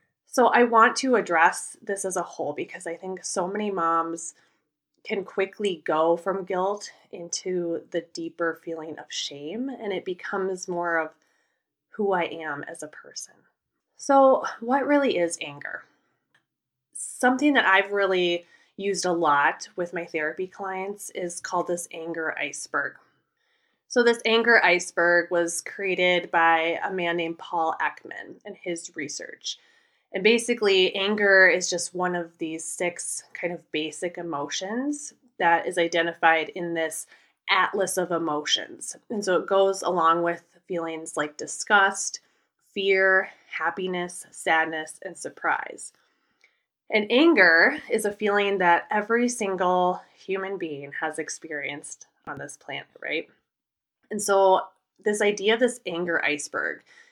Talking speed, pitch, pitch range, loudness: 140 wpm, 180 Hz, 165-205 Hz, -24 LUFS